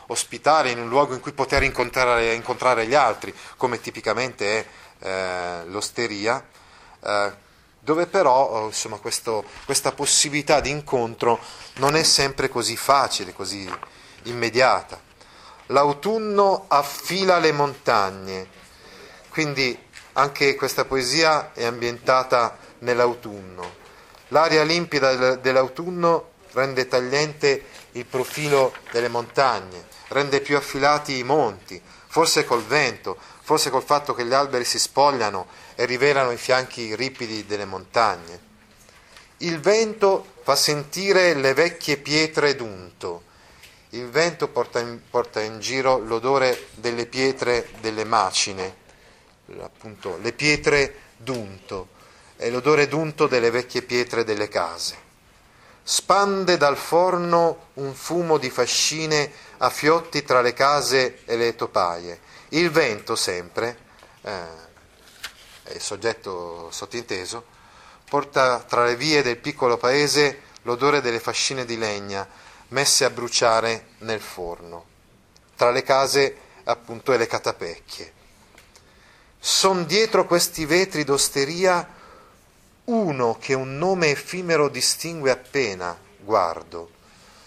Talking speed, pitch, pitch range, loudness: 115 wpm, 130 Hz, 115-150 Hz, -21 LUFS